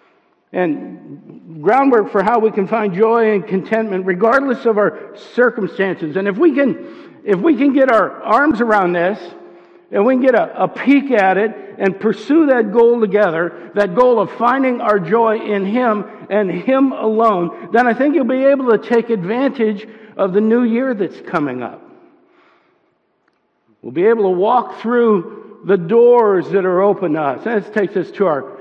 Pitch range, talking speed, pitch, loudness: 200-250 Hz, 180 wpm, 225 Hz, -15 LUFS